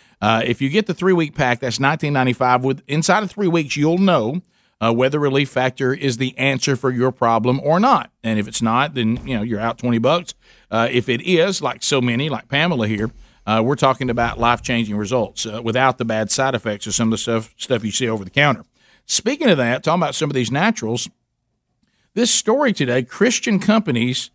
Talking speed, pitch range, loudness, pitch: 210 wpm, 115-155 Hz, -18 LUFS, 130 Hz